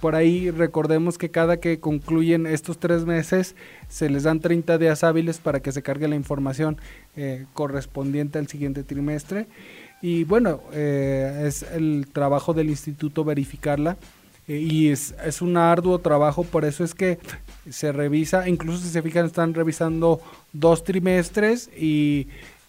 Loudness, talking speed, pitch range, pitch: -23 LUFS, 155 wpm, 150-170 Hz, 160 Hz